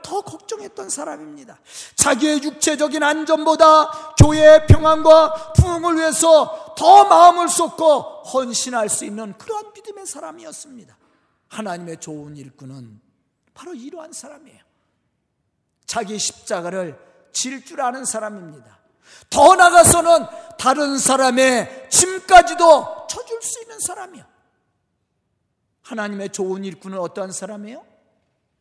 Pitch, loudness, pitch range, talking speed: 305 Hz, -15 LUFS, 220-335 Hz, 275 characters per minute